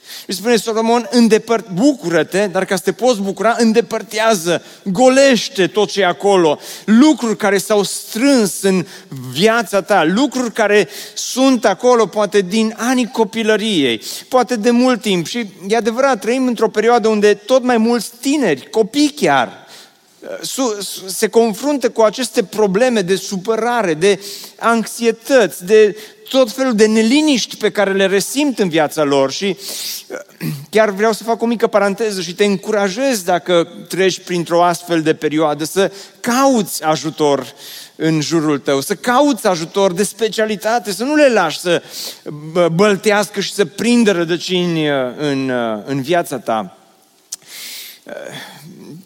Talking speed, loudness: 135 wpm, -15 LUFS